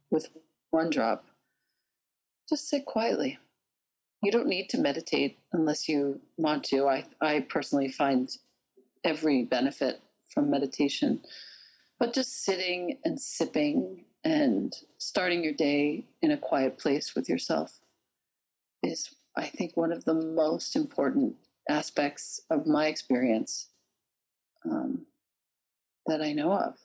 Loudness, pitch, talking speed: -30 LUFS, 170 Hz, 125 wpm